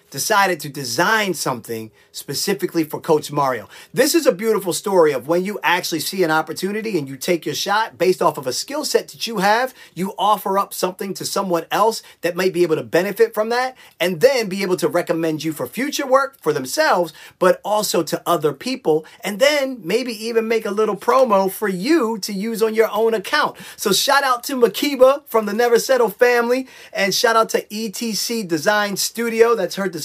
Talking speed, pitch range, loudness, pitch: 200 wpm, 170-230 Hz, -19 LUFS, 200 Hz